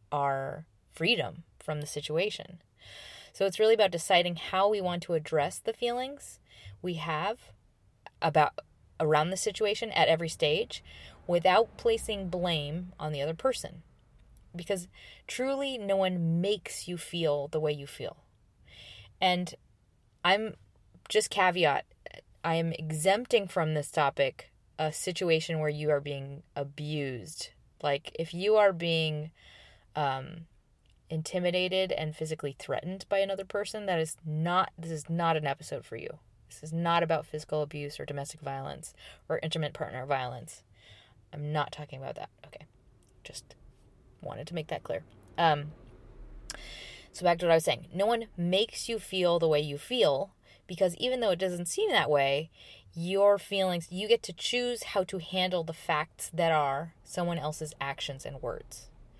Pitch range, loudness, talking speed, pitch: 145-190 Hz, -30 LUFS, 155 wpm, 165 Hz